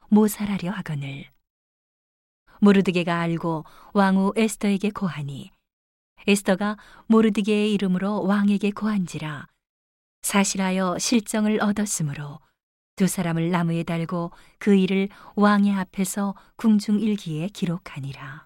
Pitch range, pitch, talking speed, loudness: 165-205 Hz, 195 Hz, 270 characters per minute, -23 LUFS